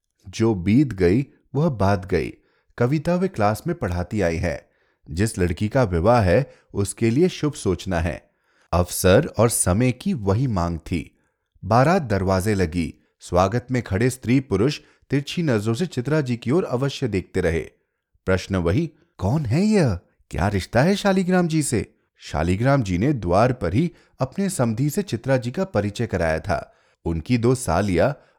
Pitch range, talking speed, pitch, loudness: 90-140 Hz, 160 wpm, 115 Hz, -22 LUFS